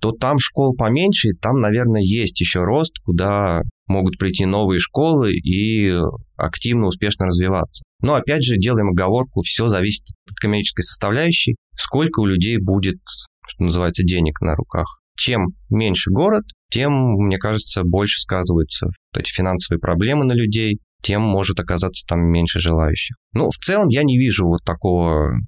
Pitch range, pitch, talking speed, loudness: 90-115 Hz, 100 Hz, 155 wpm, -18 LUFS